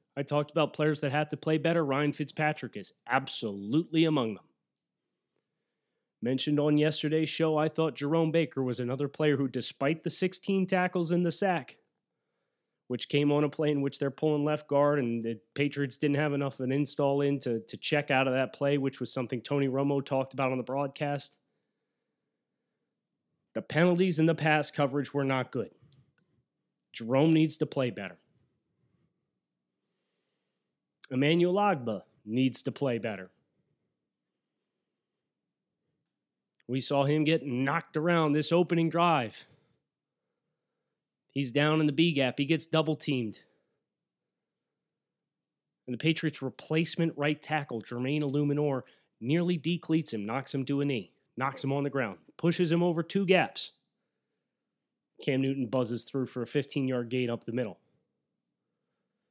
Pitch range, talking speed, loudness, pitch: 130-155 Hz, 150 wpm, -29 LUFS, 145 Hz